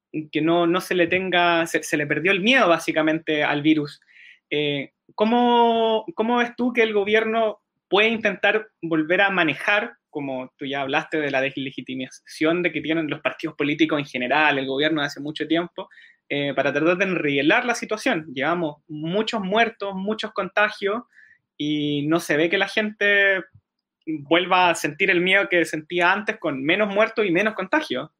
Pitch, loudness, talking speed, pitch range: 175 Hz, -21 LUFS, 175 wpm, 155-210 Hz